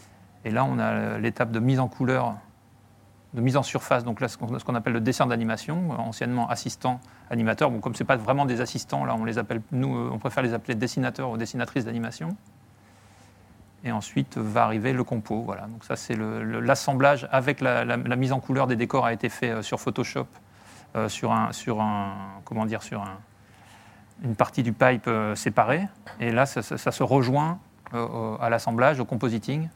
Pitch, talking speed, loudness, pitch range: 120 Hz, 200 wpm, -26 LUFS, 110-130 Hz